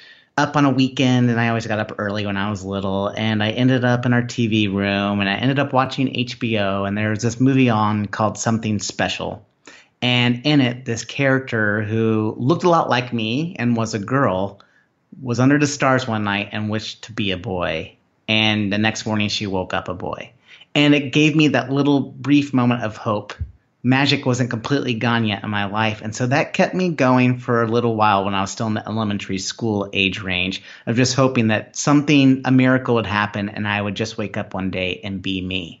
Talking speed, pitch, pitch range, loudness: 220 wpm, 115 Hz, 105-130 Hz, -19 LUFS